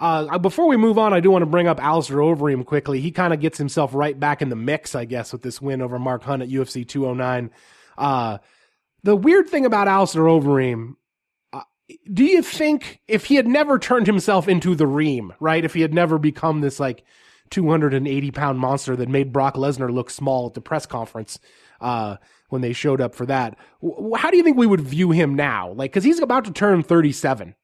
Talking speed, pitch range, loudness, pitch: 215 wpm, 130-190 Hz, -19 LUFS, 150 Hz